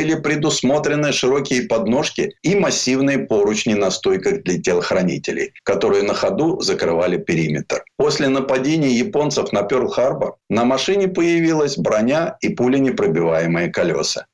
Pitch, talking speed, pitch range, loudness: 150 Hz, 115 wpm, 130-190 Hz, -18 LUFS